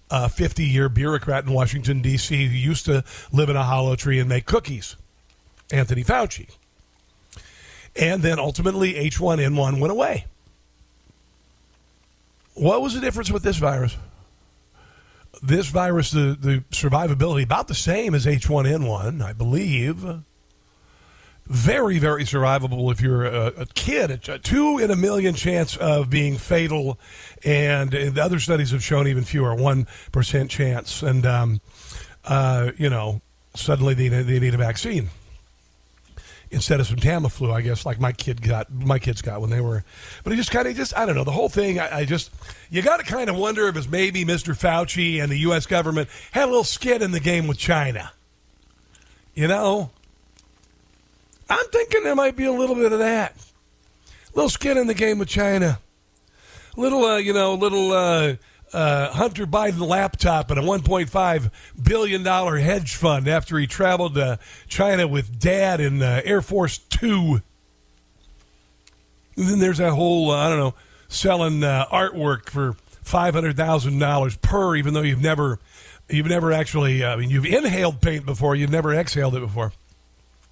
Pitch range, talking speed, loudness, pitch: 115-170 Hz, 170 wpm, -21 LUFS, 140 Hz